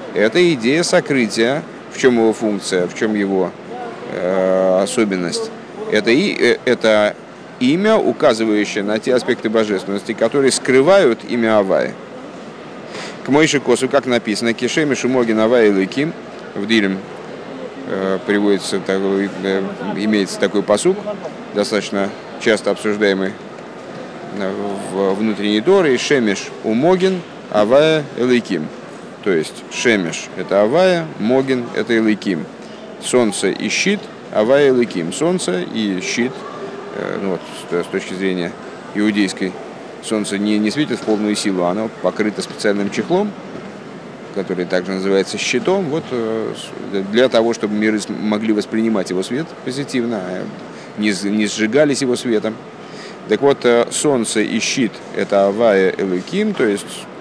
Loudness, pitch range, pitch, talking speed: -17 LUFS, 100-130 Hz, 110 Hz, 120 wpm